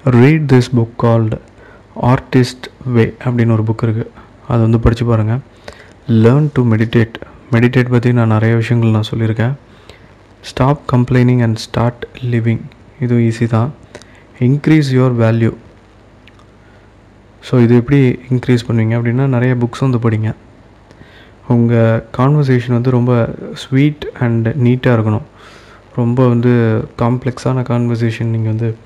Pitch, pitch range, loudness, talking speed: 120 Hz, 110-125 Hz, -13 LUFS, 125 wpm